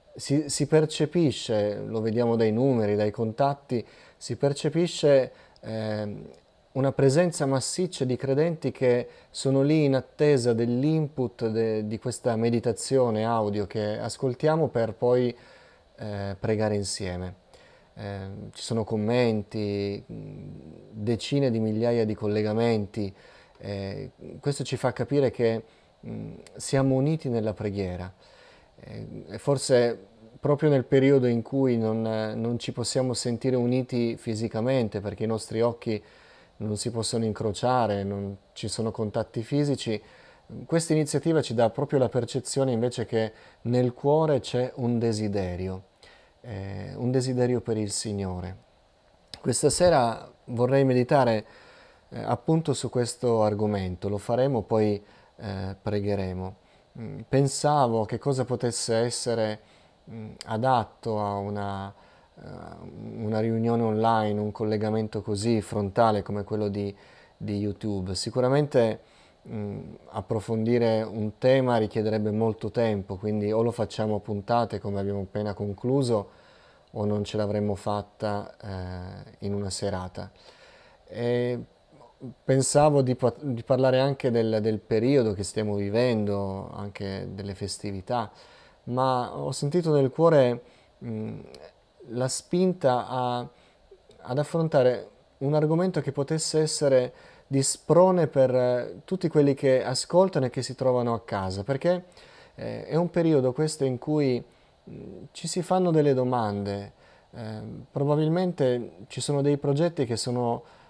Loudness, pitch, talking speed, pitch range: -26 LUFS, 120 Hz, 120 wpm, 105-135 Hz